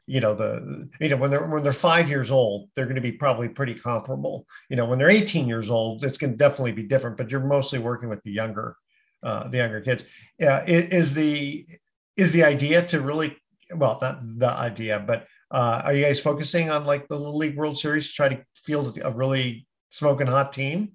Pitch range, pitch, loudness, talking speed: 120-150 Hz, 140 Hz, -24 LUFS, 220 wpm